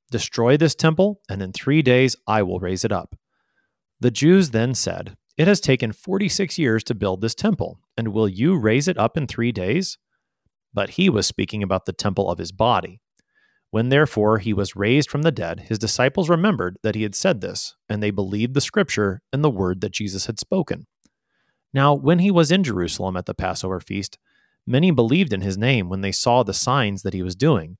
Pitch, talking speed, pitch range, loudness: 110 Hz, 210 wpm, 100-145 Hz, -21 LUFS